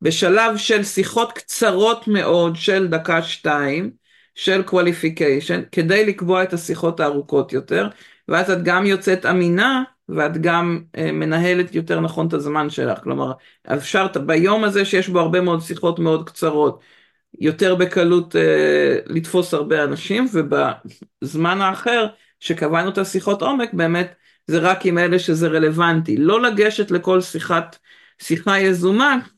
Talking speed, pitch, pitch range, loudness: 135 wpm, 175 Hz, 165-195 Hz, -18 LUFS